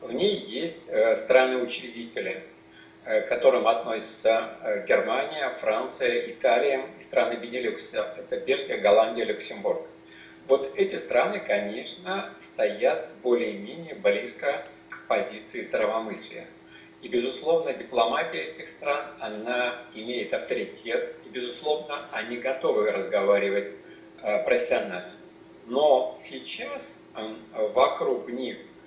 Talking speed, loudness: 95 wpm, -27 LUFS